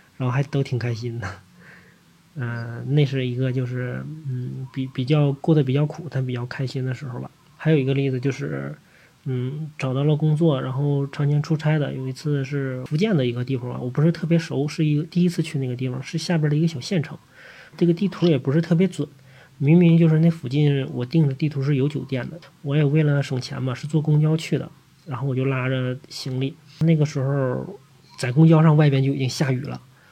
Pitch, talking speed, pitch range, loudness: 140 Hz, 310 characters per minute, 130-155 Hz, -22 LUFS